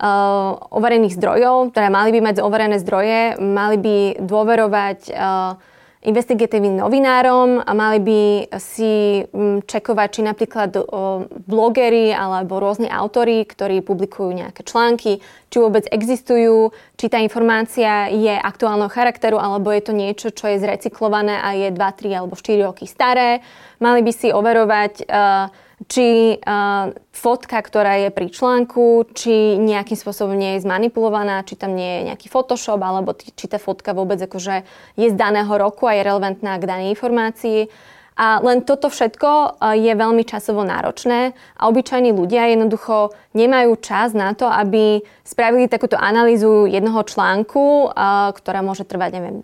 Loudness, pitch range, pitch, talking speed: -17 LUFS, 200-230 Hz, 215 Hz, 150 wpm